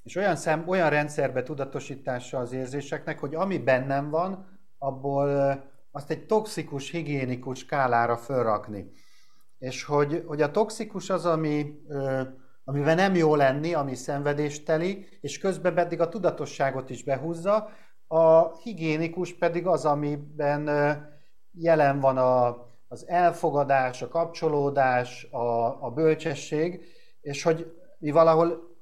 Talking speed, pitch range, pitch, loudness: 120 wpm, 135-165 Hz, 150 Hz, -26 LUFS